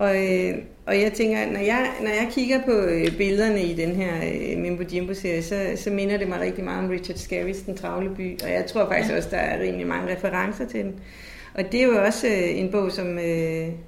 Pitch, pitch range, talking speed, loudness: 190 Hz, 180-205 Hz, 240 wpm, -24 LUFS